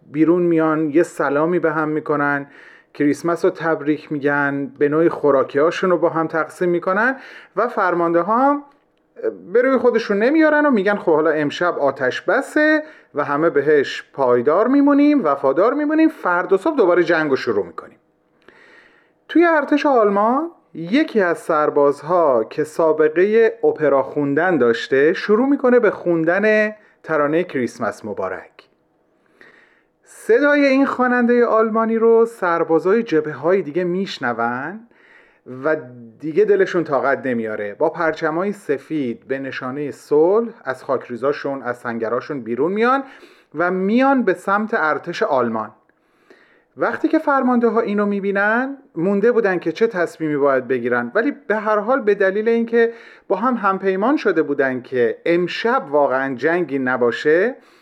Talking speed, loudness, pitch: 135 wpm, -18 LUFS, 185 Hz